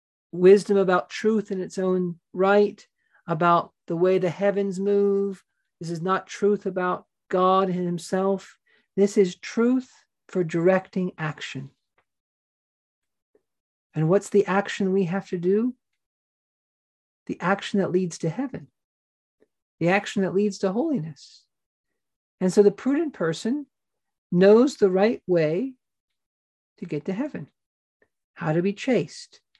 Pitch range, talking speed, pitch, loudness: 180-205 Hz, 130 wpm, 195 Hz, -23 LUFS